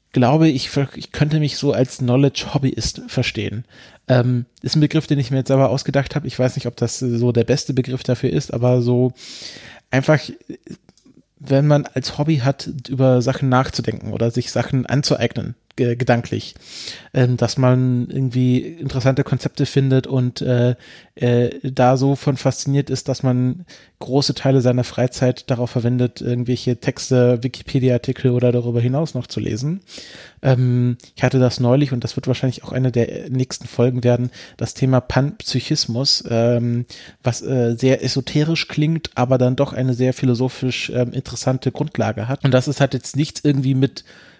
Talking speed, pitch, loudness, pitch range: 155 wpm, 130 Hz, -19 LUFS, 120-135 Hz